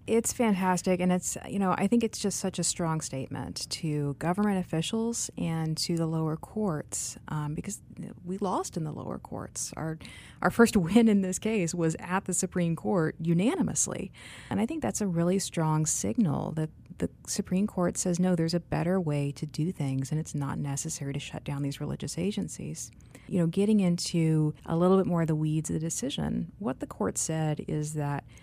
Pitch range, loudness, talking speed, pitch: 155-190 Hz, -29 LUFS, 200 wpm, 170 Hz